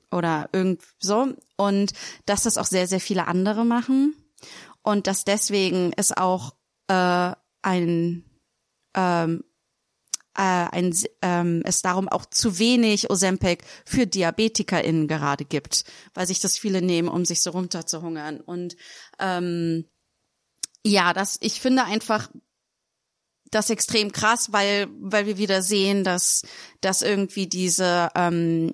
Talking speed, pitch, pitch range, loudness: 130 wpm, 185 Hz, 175-210 Hz, -23 LUFS